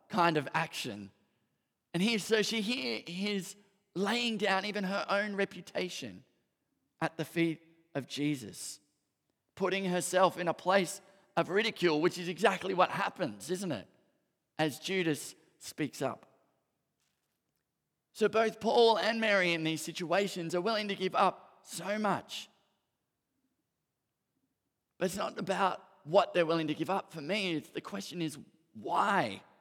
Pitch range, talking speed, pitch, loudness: 165-200 Hz, 140 wpm, 185 Hz, -32 LUFS